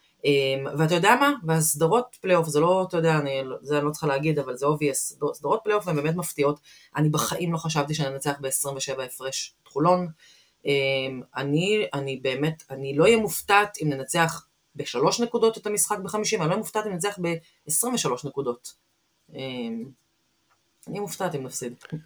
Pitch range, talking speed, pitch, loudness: 140-185 Hz, 170 wpm, 155 Hz, -25 LUFS